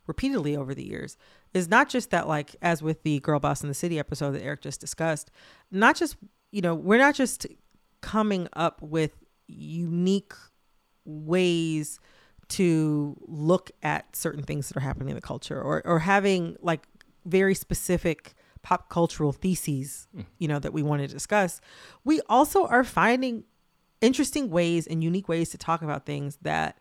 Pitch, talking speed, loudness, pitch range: 170 Hz, 170 wpm, -26 LUFS, 150-195 Hz